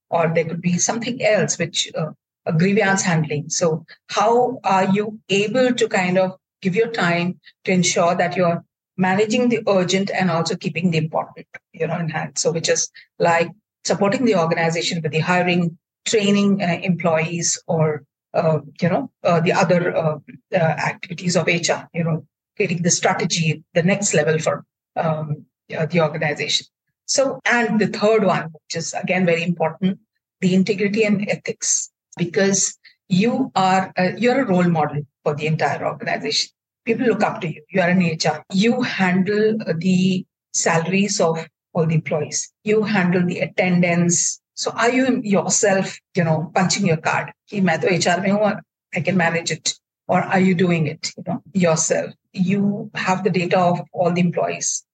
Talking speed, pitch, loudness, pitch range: 165 wpm, 180 Hz, -20 LUFS, 165-200 Hz